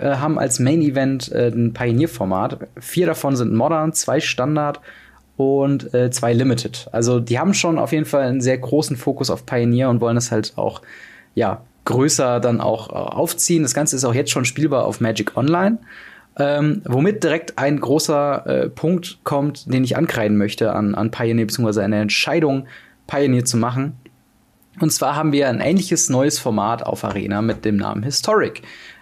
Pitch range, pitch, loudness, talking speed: 115-150 Hz, 135 Hz, -19 LUFS, 180 wpm